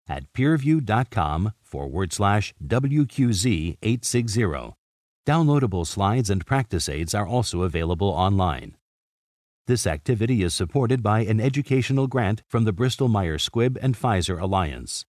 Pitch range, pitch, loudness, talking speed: 90-130 Hz, 110 Hz, -23 LUFS, 115 wpm